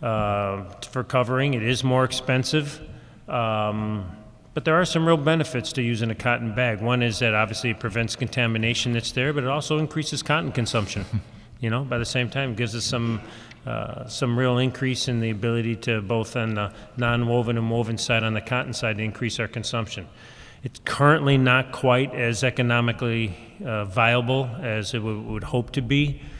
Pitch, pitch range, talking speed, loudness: 120 Hz, 115-130 Hz, 190 wpm, -24 LUFS